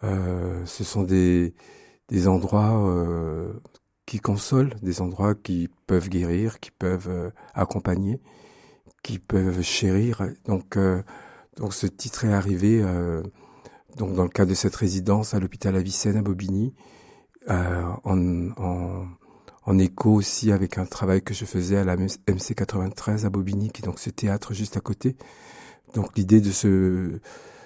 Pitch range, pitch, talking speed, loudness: 90-105 Hz, 95 Hz, 150 wpm, -24 LUFS